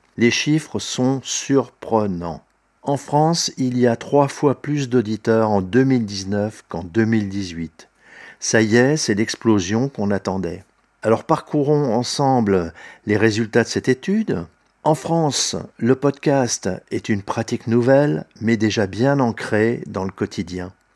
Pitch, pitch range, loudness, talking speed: 115 Hz, 105-135 Hz, -20 LUFS, 135 wpm